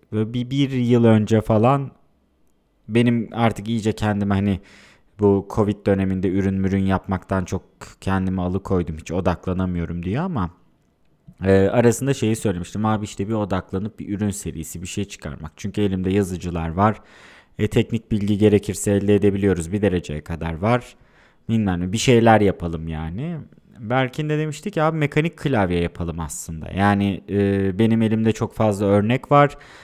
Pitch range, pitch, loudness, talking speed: 95-115 Hz, 100 Hz, -21 LUFS, 150 wpm